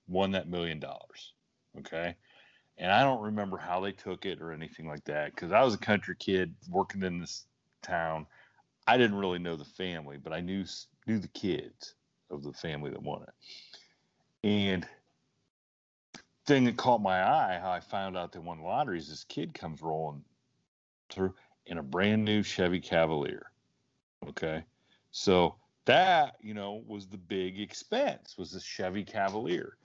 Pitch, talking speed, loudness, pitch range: 90 Hz, 165 wpm, -31 LUFS, 80-105 Hz